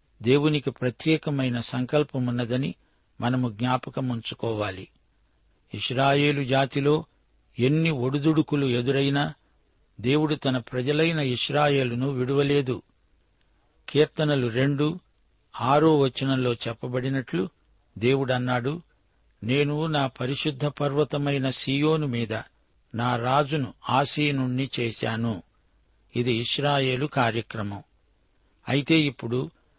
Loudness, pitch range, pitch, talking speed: -25 LUFS, 115-145 Hz, 130 Hz, 75 wpm